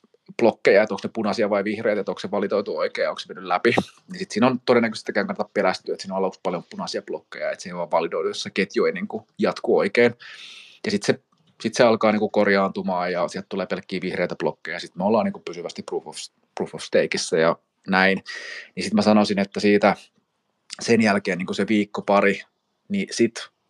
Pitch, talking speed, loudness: 125 Hz, 215 wpm, -23 LUFS